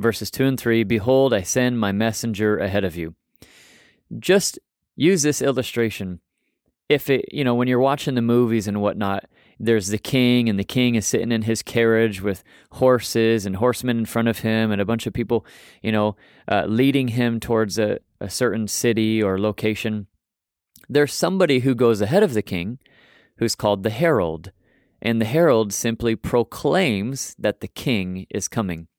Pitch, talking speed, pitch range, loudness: 115 Hz, 175 wpm, 105-125 Hz, -21 LUFS